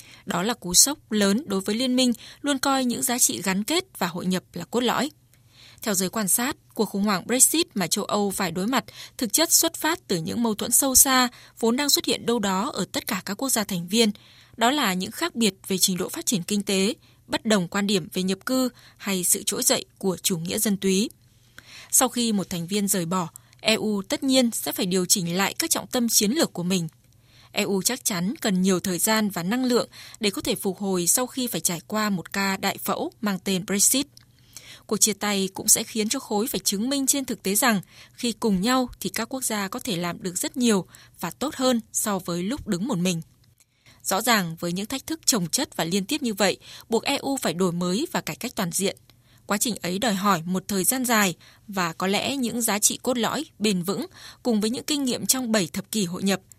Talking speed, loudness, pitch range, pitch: 240 wpm, -23 LUFS, 185-245 Hz, 210 Hz